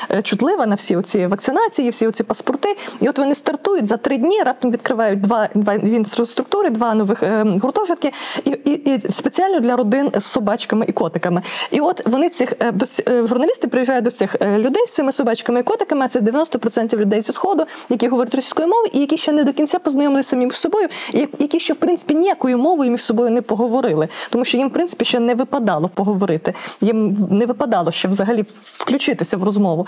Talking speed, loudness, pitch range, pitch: 195 wpm, -17 LUFS, 220-295 Hz, 250 Hz